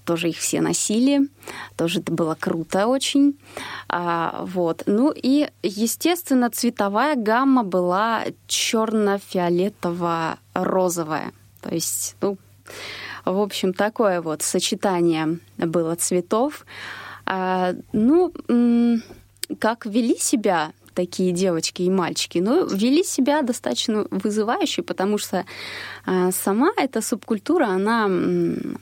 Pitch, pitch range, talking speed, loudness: 205 Hz, 180-245 Hz, 100 wpm, -22 LUFS